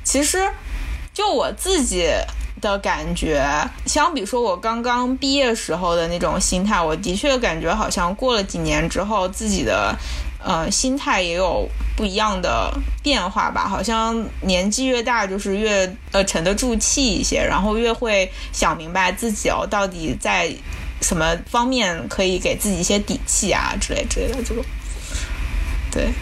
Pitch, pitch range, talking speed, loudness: 205 Hz, 175-240 Hz, 235 characters per minute, -20 LUFS